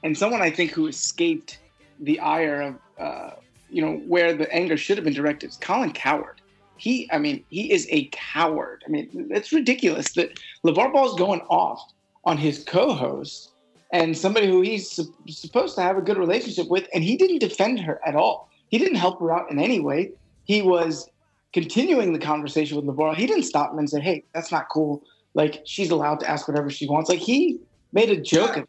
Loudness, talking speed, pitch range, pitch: -23 LUFS, 205 wpm, 155-245 Hz, 175 Hz